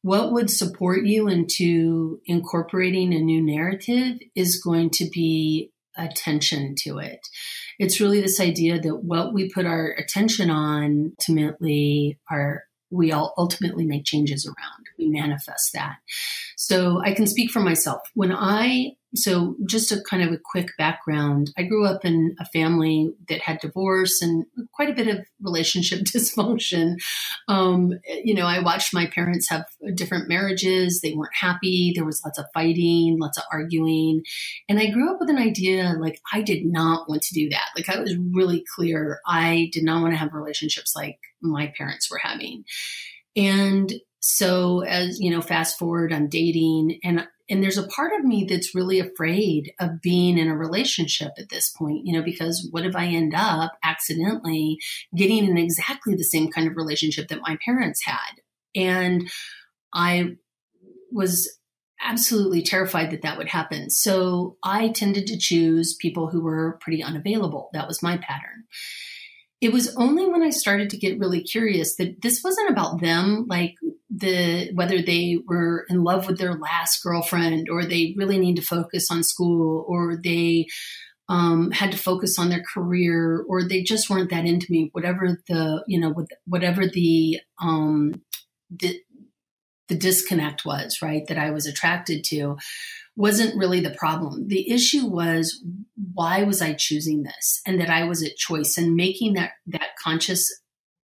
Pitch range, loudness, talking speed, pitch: 160-195 Hz, -22 LUFS, 170 wpm, 175 Hz